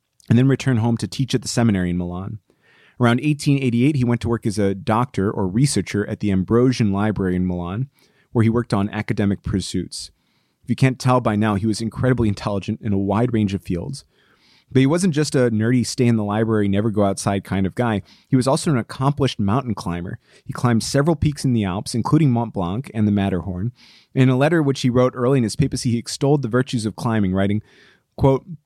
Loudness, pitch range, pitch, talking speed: -20 LUFS, 100-130 Hz, 115 Hz, 205 wpm